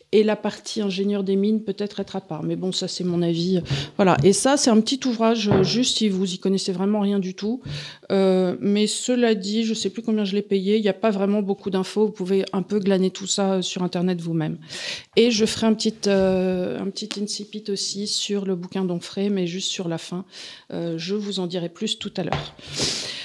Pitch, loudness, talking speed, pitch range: 195 Hz, -23 LUFS, 225 wpm, 185-210 Hz